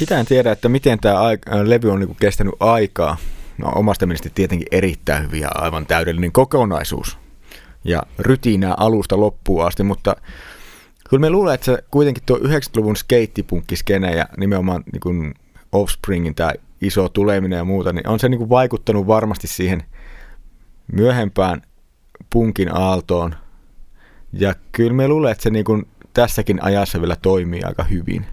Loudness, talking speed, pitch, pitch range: -18 LUFS, 140 wpm, 100 Hz, 90-115 Hz